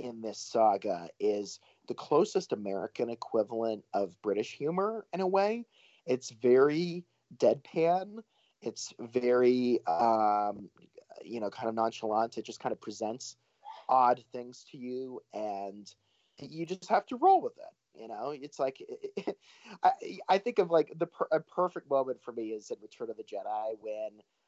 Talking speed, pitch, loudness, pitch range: 165 wpm, 125 Hz, -31 LUFS, 110-180 Hz